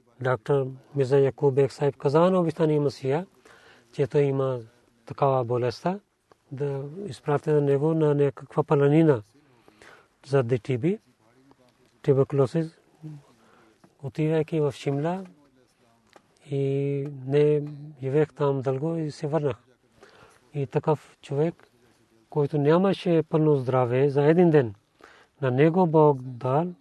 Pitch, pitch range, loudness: 140 Hz, 130-155 Hz, -25 LUFS